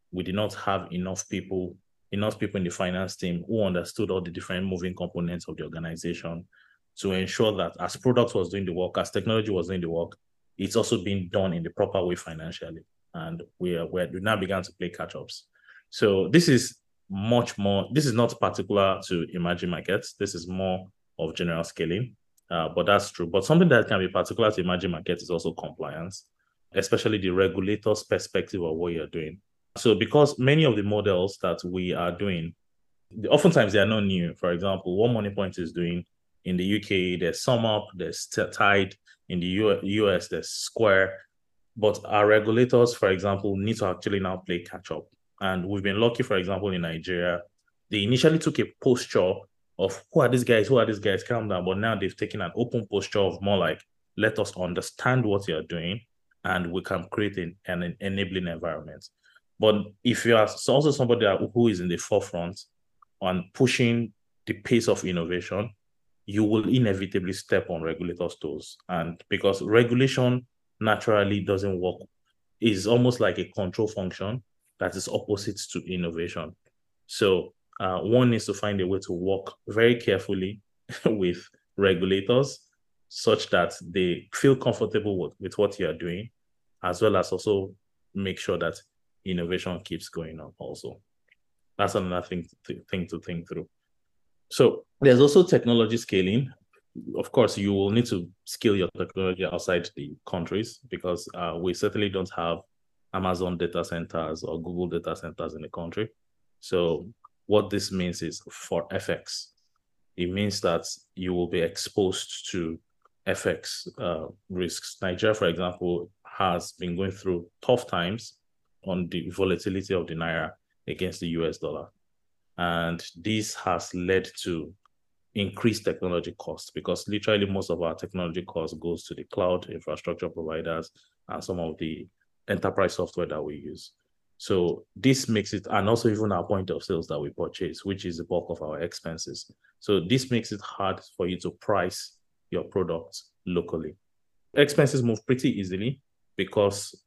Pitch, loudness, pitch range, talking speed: 95 Hz, -27 LUFS, 90-110 Hz, 170 wpm